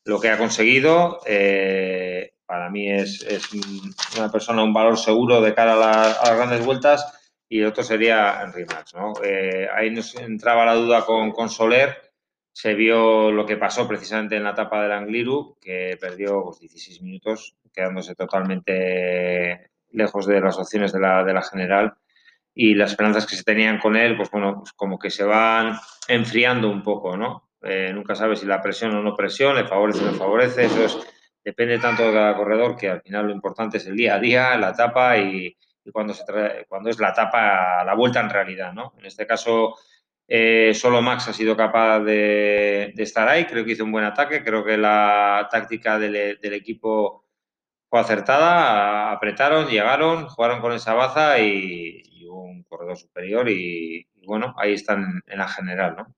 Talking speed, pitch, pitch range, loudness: 190 wpm, 110 Hz, 100-115 Hz, -20 LUFS